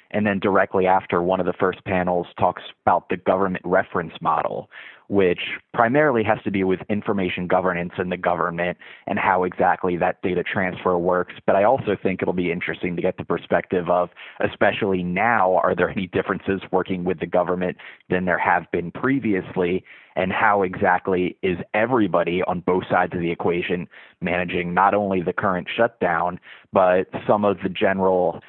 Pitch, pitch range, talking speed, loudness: 90 Hz, 90-95 Hz, 175 wpm, -22 LUFS